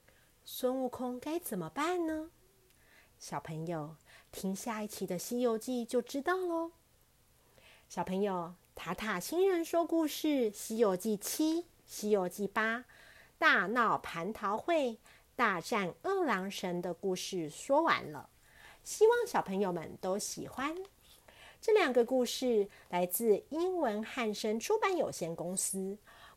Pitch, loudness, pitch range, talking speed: 225 Hz, -34 LUFS, 190-310 Hz, 200 characters per minute